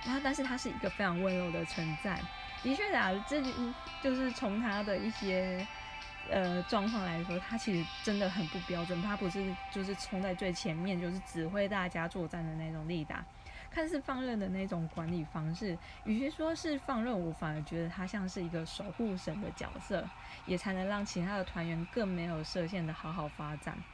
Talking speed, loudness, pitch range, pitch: 290 characters per minute, -37 LUFS, 170-210 Hz, 190 Hz